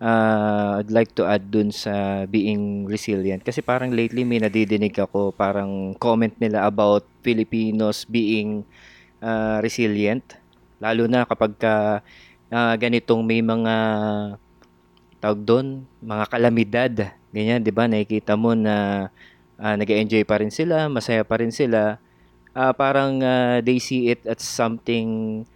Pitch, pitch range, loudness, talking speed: 110 Hz, 105-115 Hz, -21 LUFS, 135 wpm